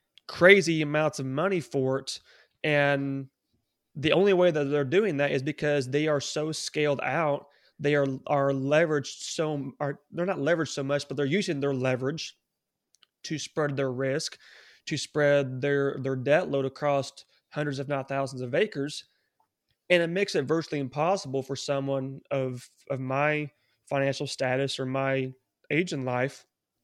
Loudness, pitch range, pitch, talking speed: -27 LUFS, 135-150 Hz, 145 Hz, 160 wpm